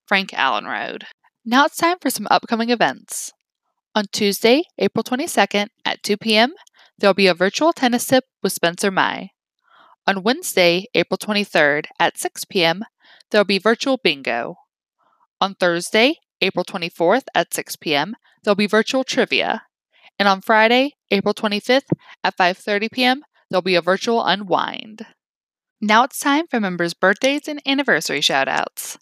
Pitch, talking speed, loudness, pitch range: 215 Hz, 155 wpm, -19 LUFS, 195-255 Hz